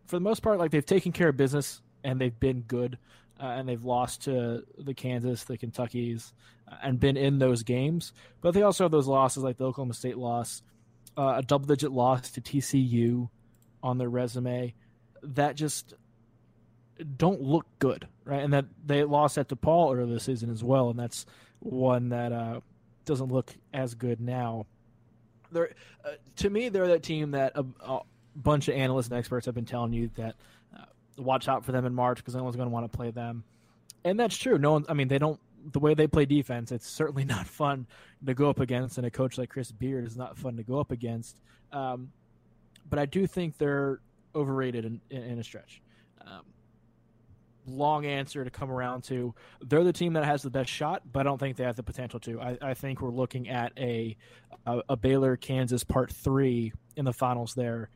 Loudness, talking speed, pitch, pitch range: -29 LUFS, 205 wpm, 130 Hz, 120-140 Hz